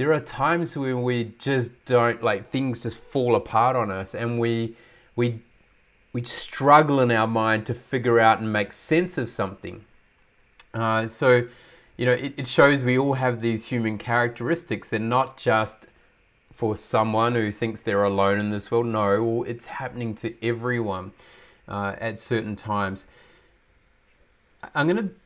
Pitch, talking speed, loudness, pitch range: 115 Hz, 155 wpm, -23 LUFS, 110-130 Hz